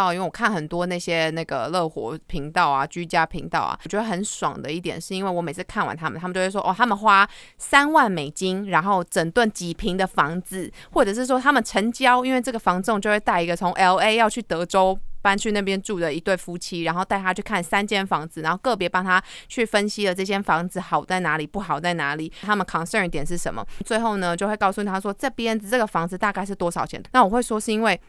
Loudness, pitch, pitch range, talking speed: -22 LUFS, 190 Hz, 170-210 Hz, 365 characters per minute